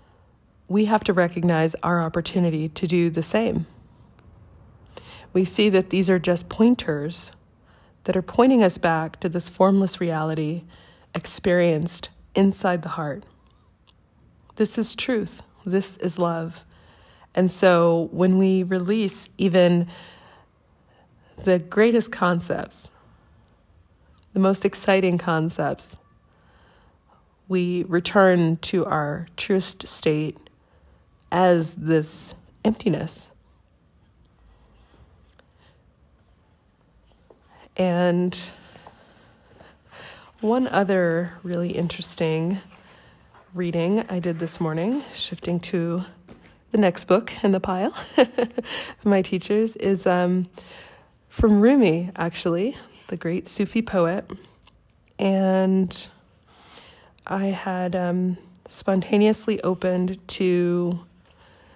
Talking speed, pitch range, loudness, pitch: 90 wpm, 160-190 Hz, -22 LUFS, 180 Hz